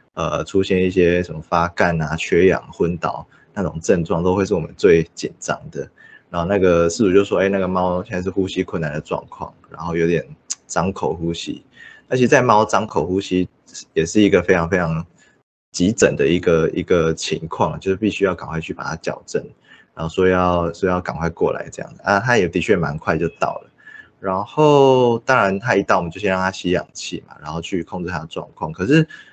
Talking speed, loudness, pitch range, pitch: 300 characters per minute, -19 LUFS, 85-95 Hz, 90 Hz